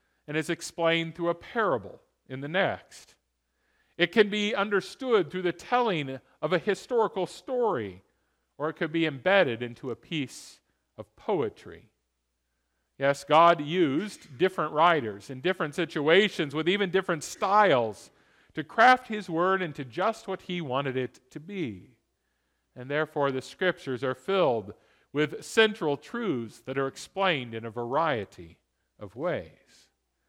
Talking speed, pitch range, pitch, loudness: 140 wpm, 130-185 Hz, 160 Hz, -27 LUFS